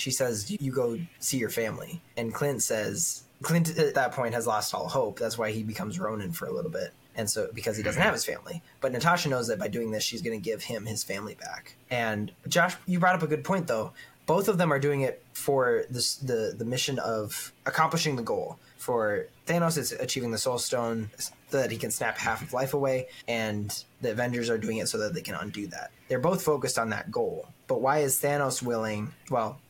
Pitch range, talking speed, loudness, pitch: 115-170 Hz, 230 wpm, -29 LUFS, 135 Hz